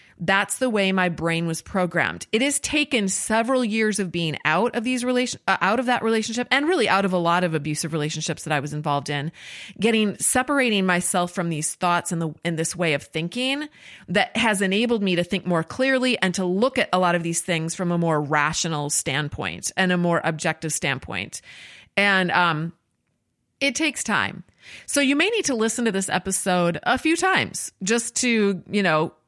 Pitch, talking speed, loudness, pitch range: 185 Hz, 200 wpm, -22 LUFS, 165-230 Hz